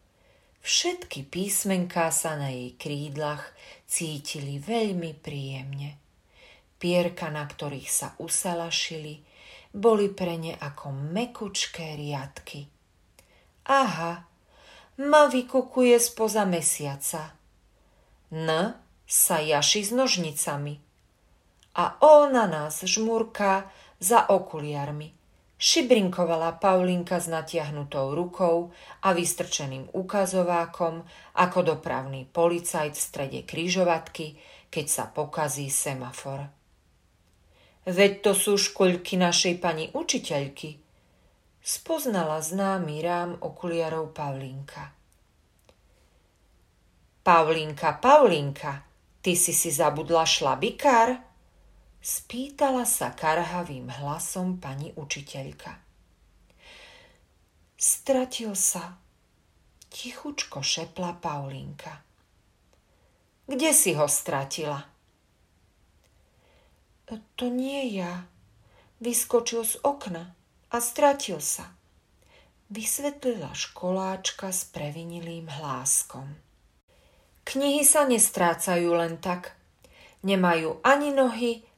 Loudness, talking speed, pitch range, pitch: -25 LUFS, 80 wpm, 145-200 Hz, 170 Hz